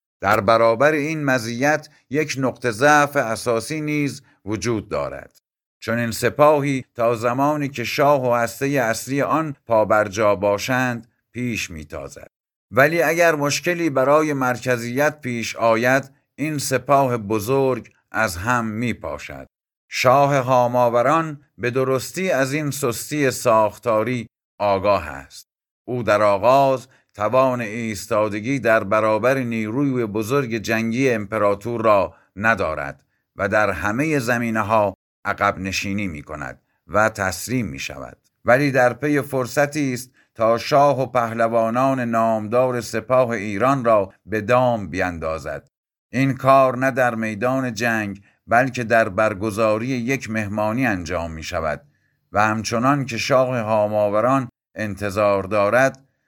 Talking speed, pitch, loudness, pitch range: 120 wpm, 120 Hz, -20 LUFS, 110-135 Hz